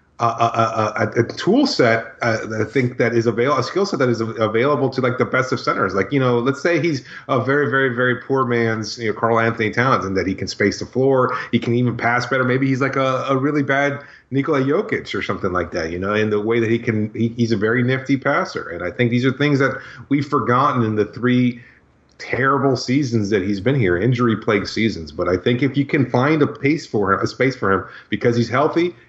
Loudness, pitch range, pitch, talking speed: -19 LUFS, 115-135 Hz, 125 Hz, 250 wpm